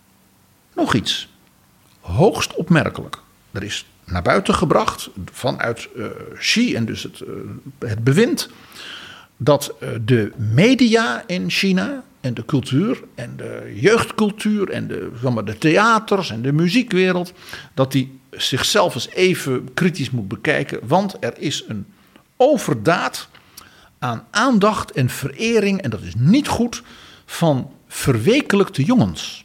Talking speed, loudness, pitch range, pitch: 130 wpm, -19 LUFS, 130-215 Hz, 175 Hz